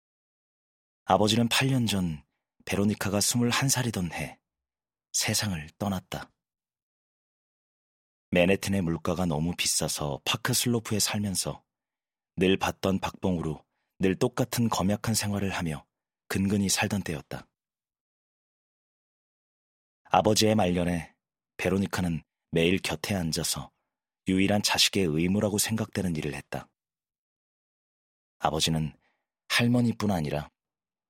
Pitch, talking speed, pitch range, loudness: 95 Hz, 225 characters per minute, 85-110 Hz, -27 LUFS